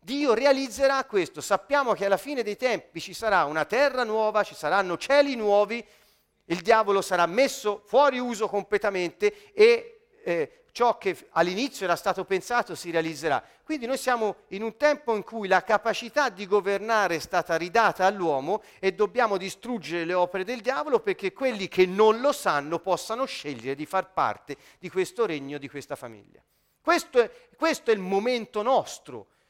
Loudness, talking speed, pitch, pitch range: -25 LUFS, 165 wpm, 210 Hz, 180-255 Hz